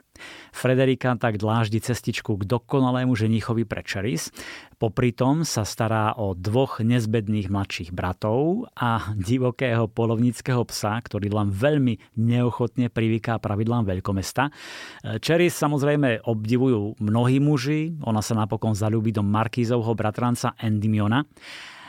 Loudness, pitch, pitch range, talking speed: -24 LUFS, 115 Hz, 110-125 Hz, 115 wpm